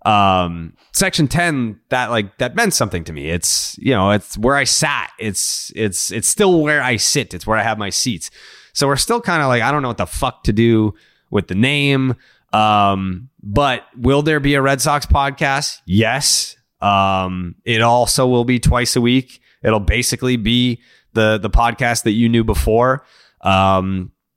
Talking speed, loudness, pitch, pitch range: 185 wpm, -16 LUFS, 120 Hz, 105-135 Hz